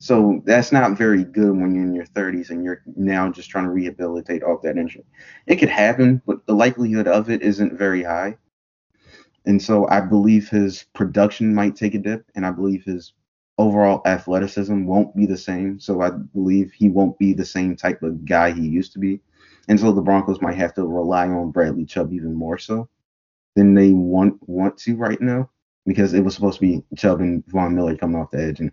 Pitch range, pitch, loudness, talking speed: 90-105 Hz, 95 Hz, -19 LUFS, 215 wpm